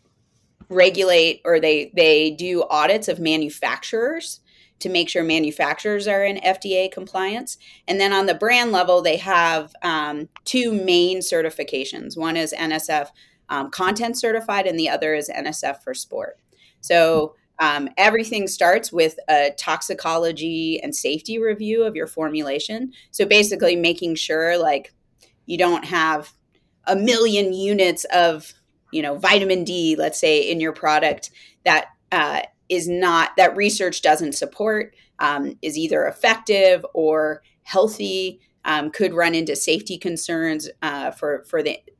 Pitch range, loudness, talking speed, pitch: 160-205 Hz, -20 LUFS, 140 wpm, 180 Hz